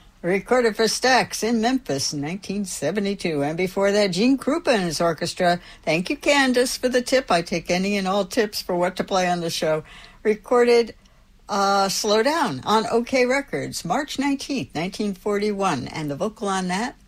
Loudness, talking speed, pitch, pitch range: -22 LUFS, 185 wpm, 205 Hz, 180-240 Hz